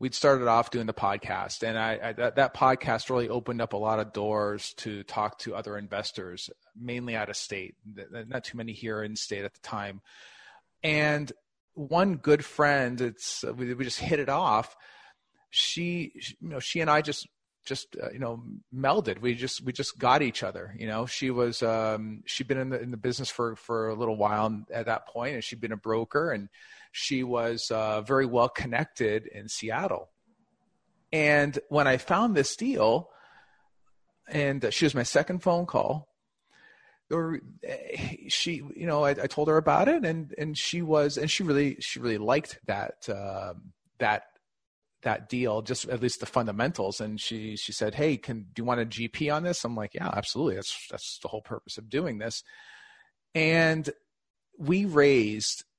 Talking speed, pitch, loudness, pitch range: 185 wpm, 125 Hz, -28 LUFS, 110-150 Hz